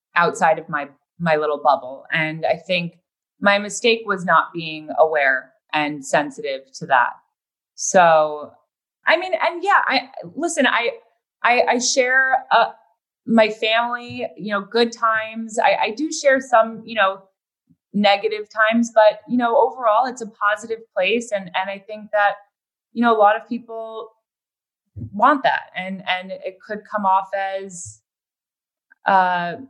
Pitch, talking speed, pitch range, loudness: 210 Hz, 150 wpm, 185-235 Hz, -19 LUFS